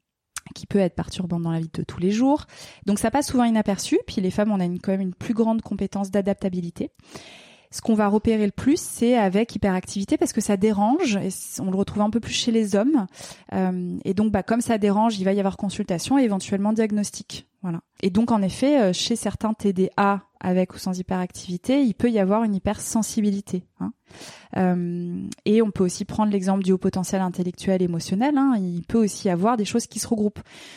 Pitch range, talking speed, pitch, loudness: 190-225 Hz, 205 wpm, 205 Hz, -23 LUFS